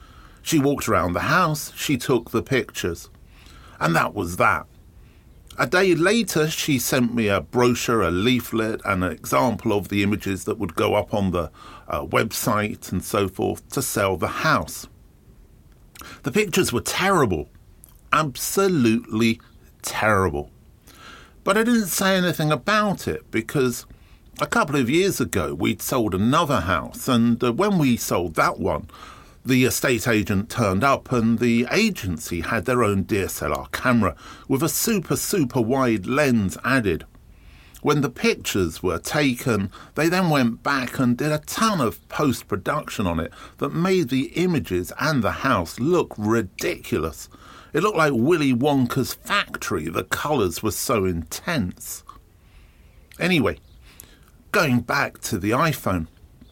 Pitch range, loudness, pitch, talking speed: 95-145 Hz, -22 LUFS, 115 Hz, 145 wpm